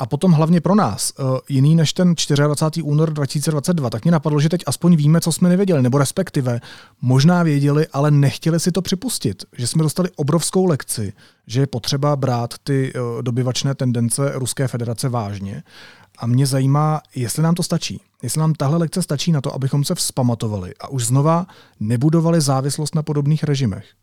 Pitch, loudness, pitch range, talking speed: 145 Hz, -18 LUFS, 130-165 Hz, 175 wpm